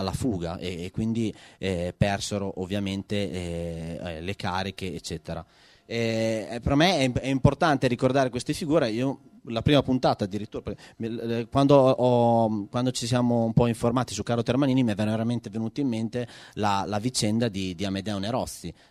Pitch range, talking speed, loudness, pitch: 100-125 Hz, 145 wpm, -26 LUFS, 115 Hz